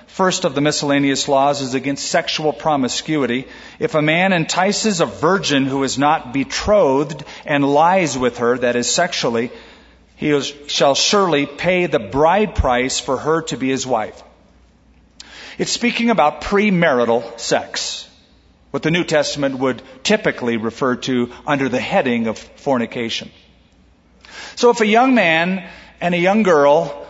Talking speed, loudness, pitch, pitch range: 145 wpm, -17 LUFS, 145 Hz, 130-175 Hz